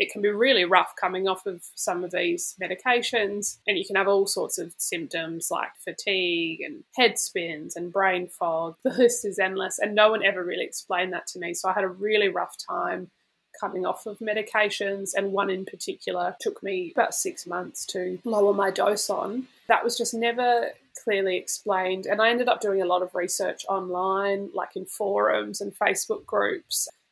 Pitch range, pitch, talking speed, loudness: 185-235 Hz, 200 Hz, 195 wpm, -25 LUFS